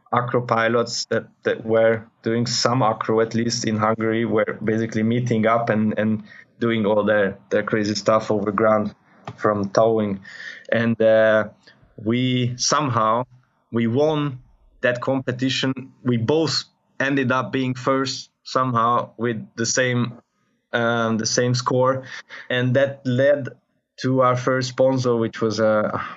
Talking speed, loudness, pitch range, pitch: 140 wpm, -21 LUFS, 110-130 Hz, 120 Hz